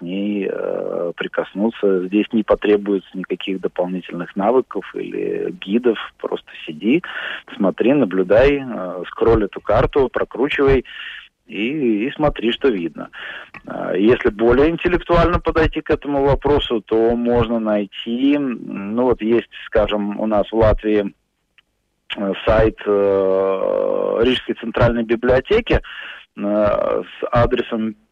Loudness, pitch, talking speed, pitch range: -18 LUFS, 120 Hz, 100 wpm, 105-155 Hz